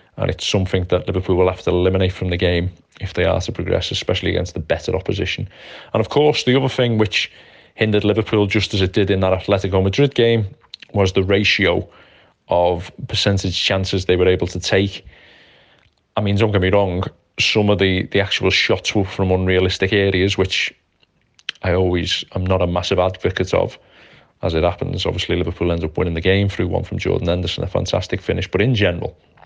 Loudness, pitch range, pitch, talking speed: -18 LUFS, 90-100 Hz, 95 Hz, 200 wpm